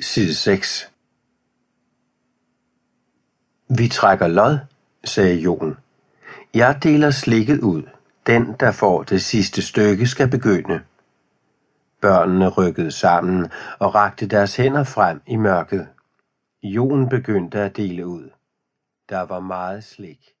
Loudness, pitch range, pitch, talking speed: -18 LUFS, 95-125 Hz, 105 Hz, 110 wpm